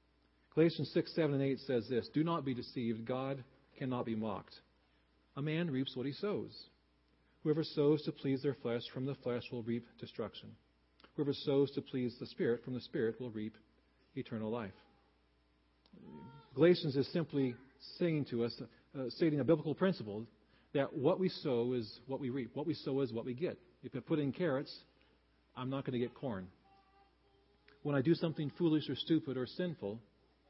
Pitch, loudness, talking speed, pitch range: 130 Hz, -37 LUFS, 180 wpm, 115-150 Hz